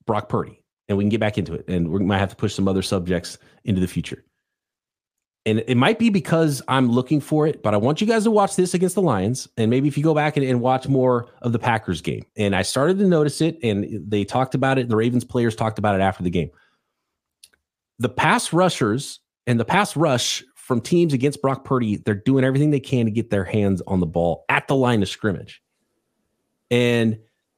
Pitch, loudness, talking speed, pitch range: 120 Hz, -21 LUFS, 230 wpm, 105-145 Hz